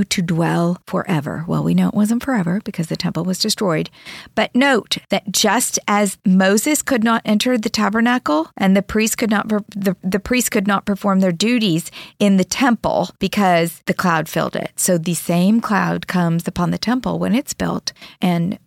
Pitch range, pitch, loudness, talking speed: 180-220 Hz, 195 Hz, -18 LUFS, 185 wpm